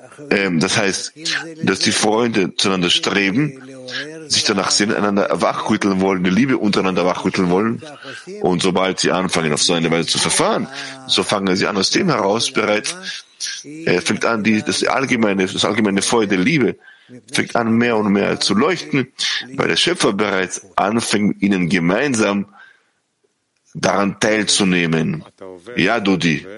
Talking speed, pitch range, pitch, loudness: 150 wpm, 95-110 Hz, 100 Hz, -17 LUFS